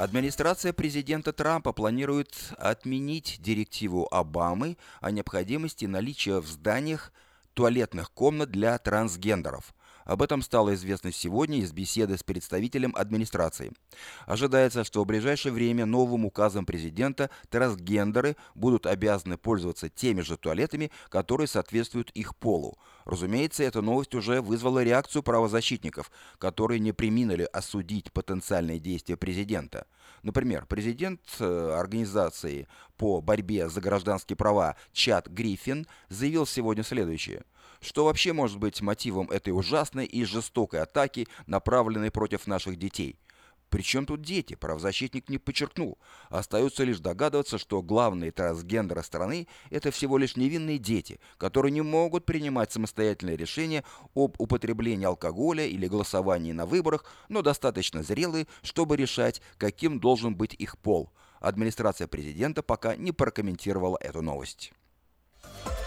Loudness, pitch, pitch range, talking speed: -29 LUFS, 110 Hz, 95-135 Hz, 120 wpm